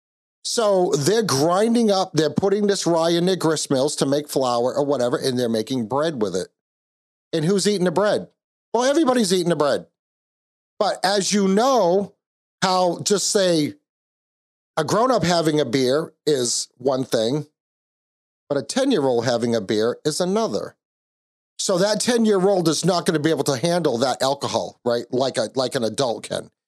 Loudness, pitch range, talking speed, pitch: -21 LUFS, 135-200 Hz, 170 wpm, 165 Hz